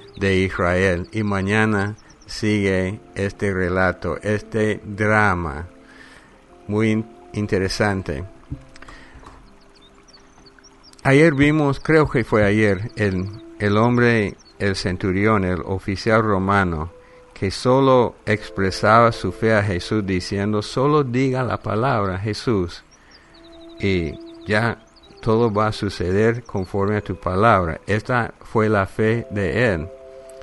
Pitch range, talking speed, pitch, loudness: 95-115 Hz, 105 wpm, 105 Hz, -20 LUFS